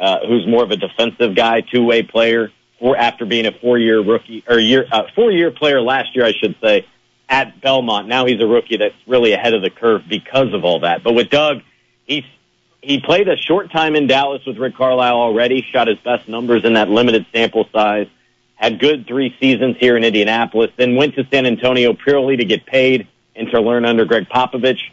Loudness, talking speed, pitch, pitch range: -15 LUFS, 210 wpm, 120 Hz, 115-135 Hz